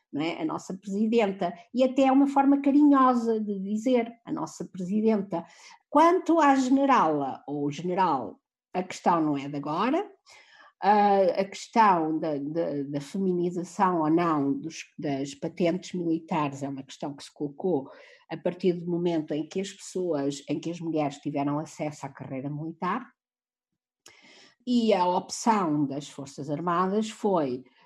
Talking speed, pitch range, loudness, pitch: 140 wpm, 150-220 Hz, -27 LUFS, 175 Hz